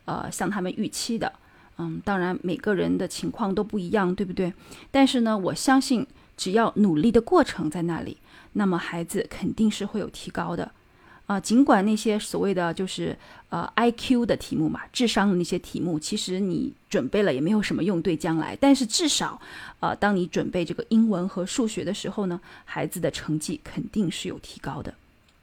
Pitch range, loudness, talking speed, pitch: 180-225 Hz, -25 LUFS, 290 characters per minute, 200 Hz